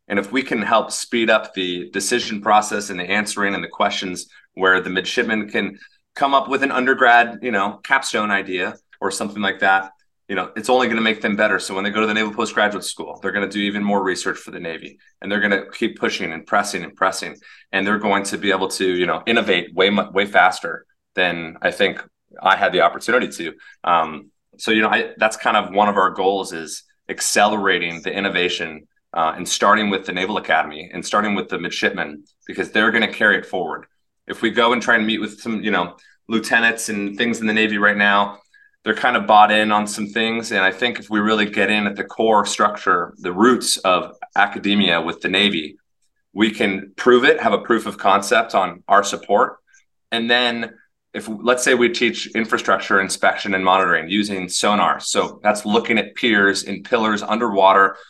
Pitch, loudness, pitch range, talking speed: 105 Hz, -18 LUFS, 100-115 Hz, 215 wpm